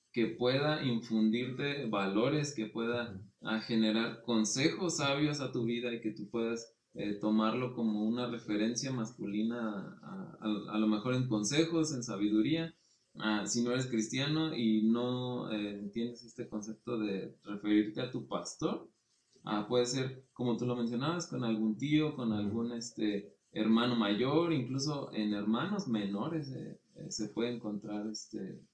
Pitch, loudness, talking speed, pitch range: 115 Hz, -34 LUFS, 150 wpm, 110-125 Hz